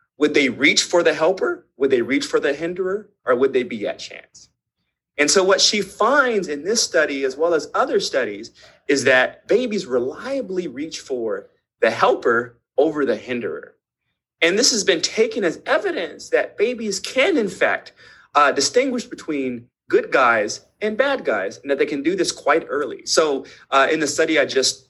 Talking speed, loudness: 185 wpm, -19 LUFS